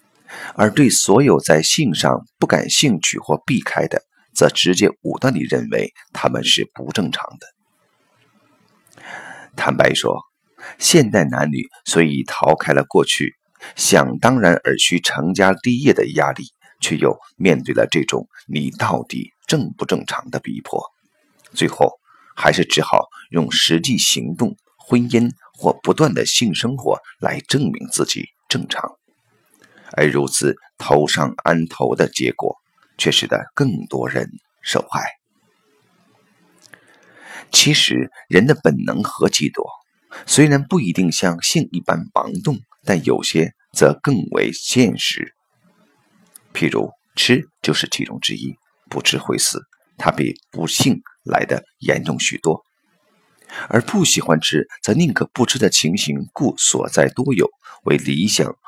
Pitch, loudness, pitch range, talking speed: 90 Hz, -17 LUFS, 80-125 Hz, 195 characters per minute